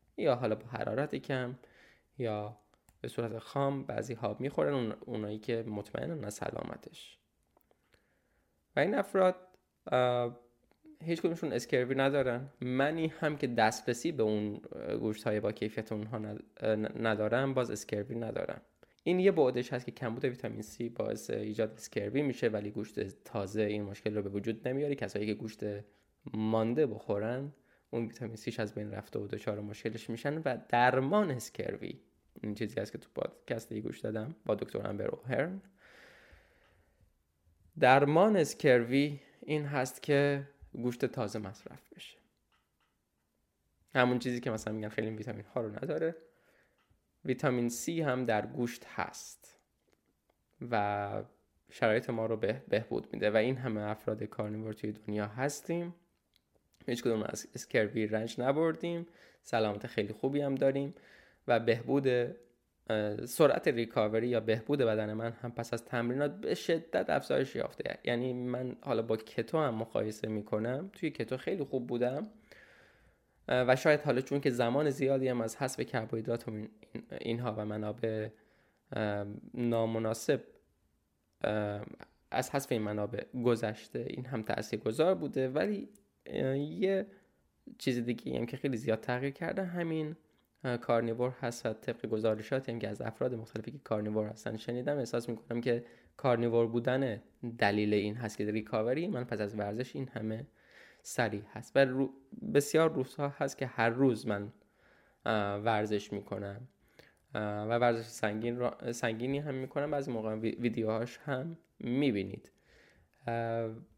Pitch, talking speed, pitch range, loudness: 120 Hz, 135 wpm, 110-135 Hz, -34 LUFS